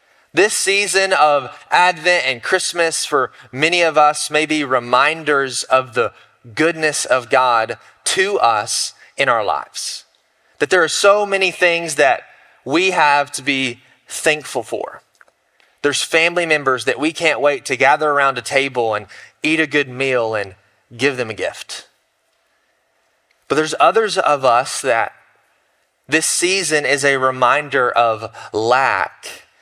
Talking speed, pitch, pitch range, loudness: 145 wpm, 150 Hz, 130-175 Hz, -16 LUFS